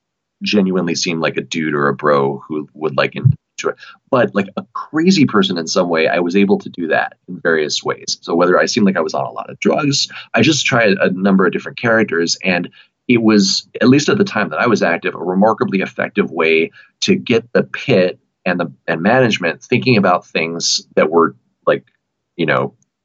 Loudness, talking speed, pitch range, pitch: -15 LUFS, 210 wpm, 80-110 Hz, 95 Hz